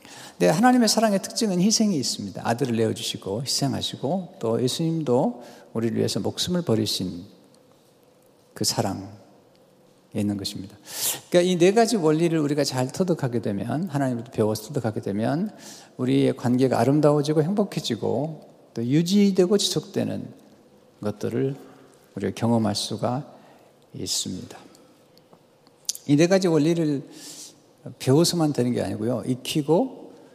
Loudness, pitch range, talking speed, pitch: -23 LUFS, 115-165 Hz, 305 characters per minute, 135 Hz